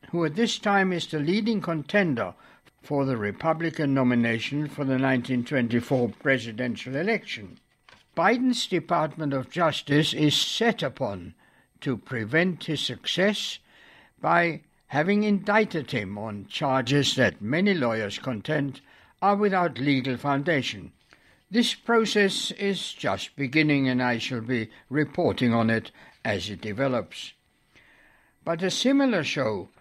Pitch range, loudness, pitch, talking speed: 130-185 Hz, -25 LUFS, 150 Hz, 125 wpm